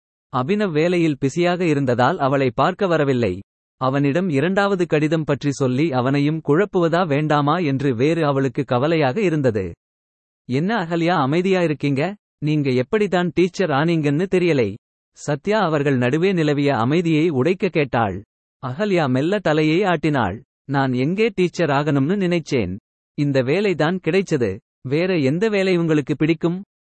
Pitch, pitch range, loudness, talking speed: 155 Hz, 135-175 Hz, -19 LUFS, 115 wpm